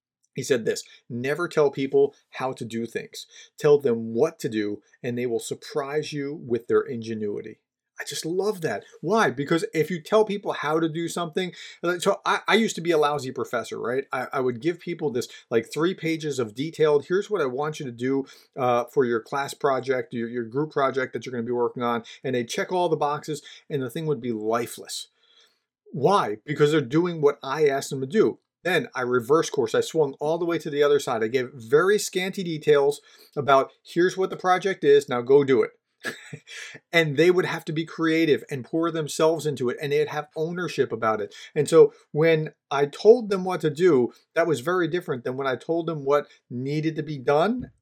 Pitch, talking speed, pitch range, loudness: 155 Hz, 215 wpm, 135-185 Hz, -24 LUFS